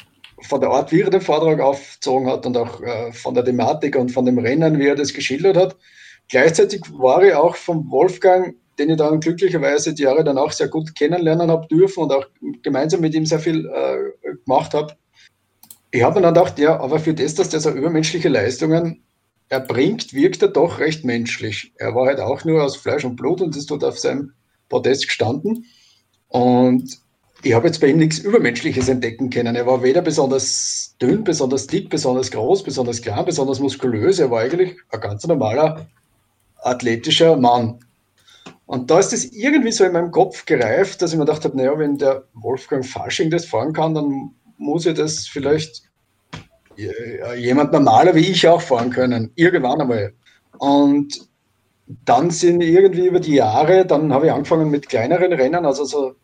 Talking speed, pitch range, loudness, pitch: 185 wpm, 130-170 Hz, -17 LUFS, 150 Hz